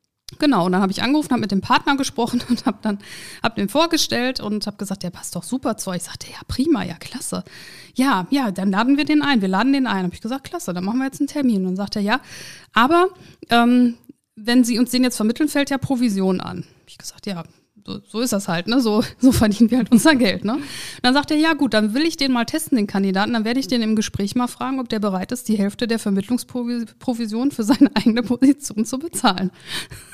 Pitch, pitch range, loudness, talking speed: 240 Hz, 205-265 Hz, -20 LUFS, 245 wpm